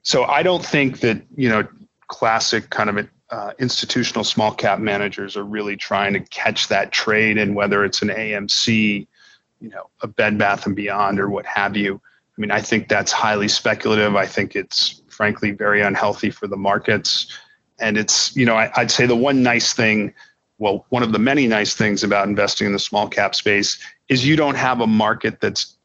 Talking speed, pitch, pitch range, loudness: 195 wpm, 105 Hz, 100-115 Hz, -18 LUFS